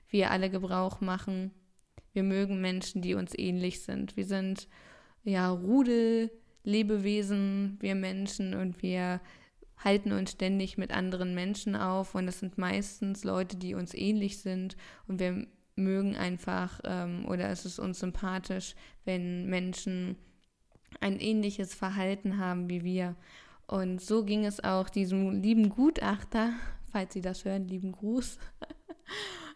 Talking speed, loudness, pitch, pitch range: 140 wpm, -33 LUFS, 190 Hz, 185-200 Hz